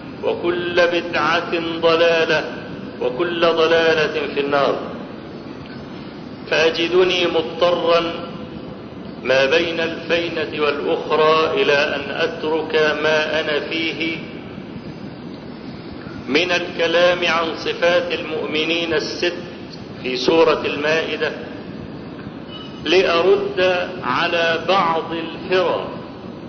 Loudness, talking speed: -18 LUFS, 70 wpm